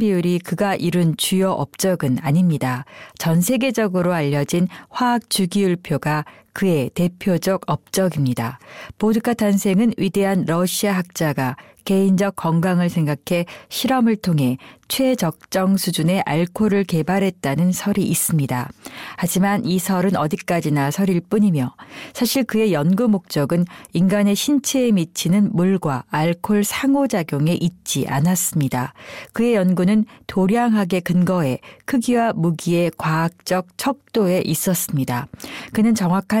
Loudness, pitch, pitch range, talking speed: -19 LUFS, 180 Hz, 165-205 Hz, 290 characters per minute